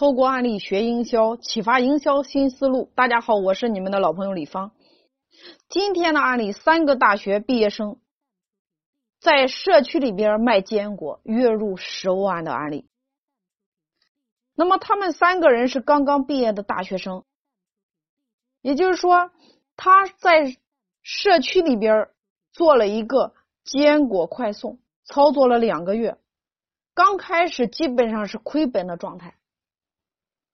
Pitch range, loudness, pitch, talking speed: 205-290 Hz, -20 LUFS, 250 Hz, 210 characters per minute